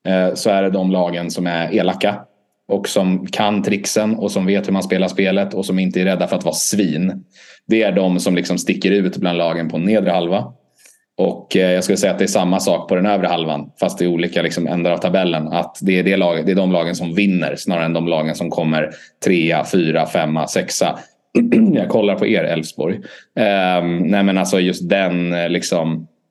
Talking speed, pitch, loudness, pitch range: 210 wpm, 90 Hz, -17 LUFS, 85-95 Hz